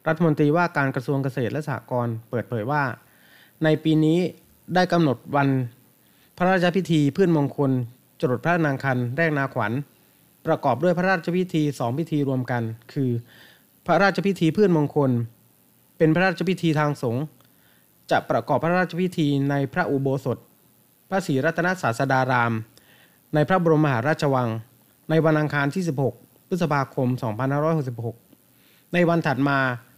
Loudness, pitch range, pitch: -23 LUFS, 125-165 Hz, 145 Hz